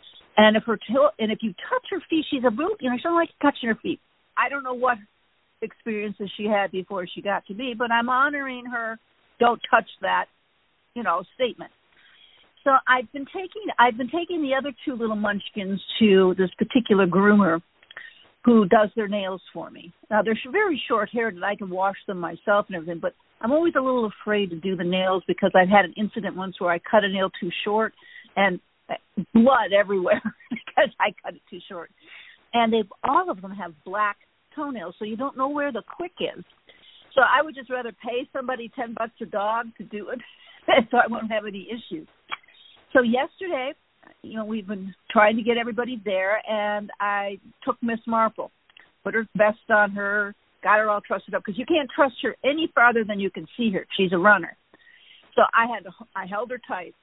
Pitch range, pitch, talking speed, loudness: 200-255 Hz, 225 Hz, 205 wpm, -23 LUFS